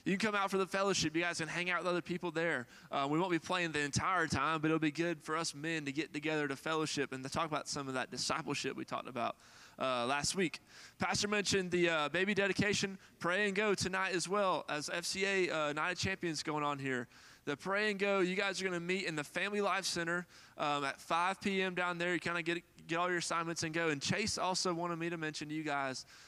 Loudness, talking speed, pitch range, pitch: -35 LUFS, 255 wpm, 150-185 Hz, 170 Hz